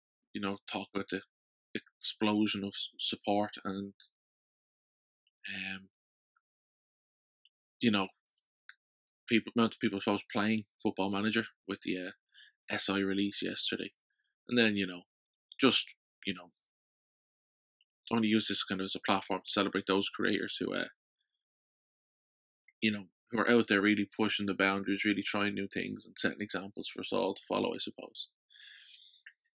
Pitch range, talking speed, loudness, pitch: 95-110 Hz, 145 wpm, -33 LUFS, 100 Hz